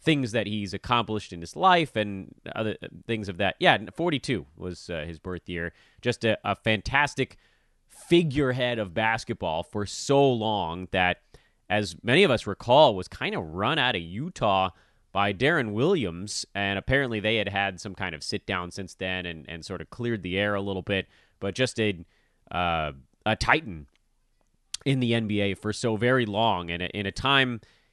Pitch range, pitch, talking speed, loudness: 95-120 Hz, 105 Hz, 180 wpm, -26 LUFS